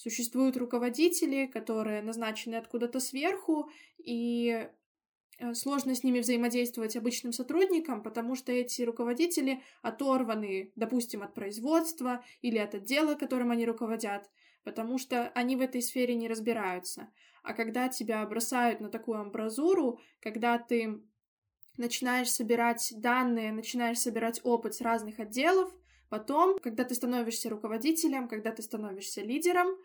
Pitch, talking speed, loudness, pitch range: 240 Hz, 125 wpm, -32 LUFS, 225-260 Hz